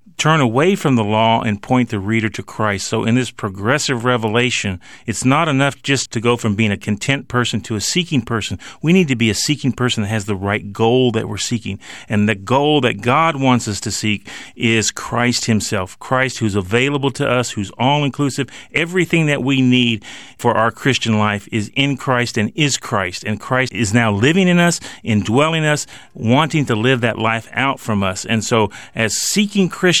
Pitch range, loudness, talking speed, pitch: 110-140 Hz, -17 LUFS, 205 wpm, 120 Hz